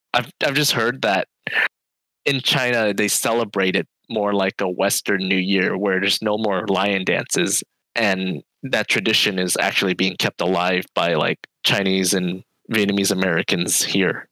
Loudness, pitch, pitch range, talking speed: -20 LUFS, 95 Hz, 95-105 Hz, 155 wpm